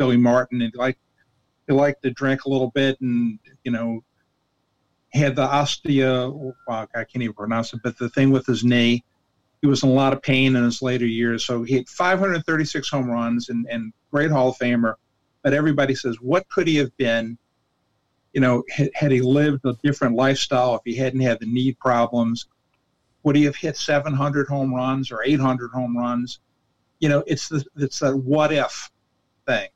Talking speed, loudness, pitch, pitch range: 195 wpm, -21 LUFS, 130 Hz, 120-140 Hz